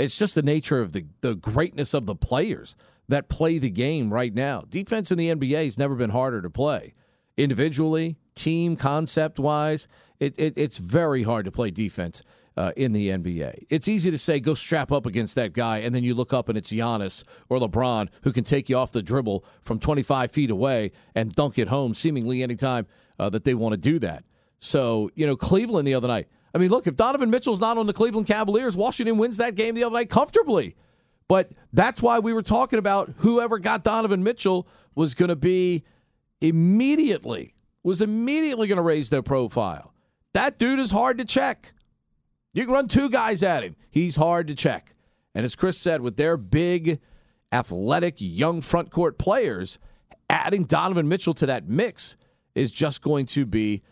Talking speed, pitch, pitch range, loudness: 195 wpm, 155 Hz, 125-190 Hz, -24 LUFS